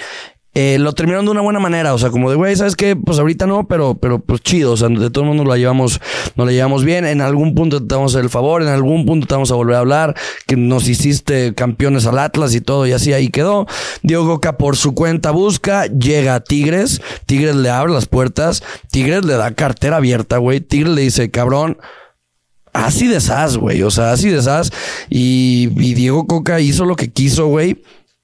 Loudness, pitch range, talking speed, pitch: -14 LUFS, 125-165 Hz, 220 wpm, 140 Hz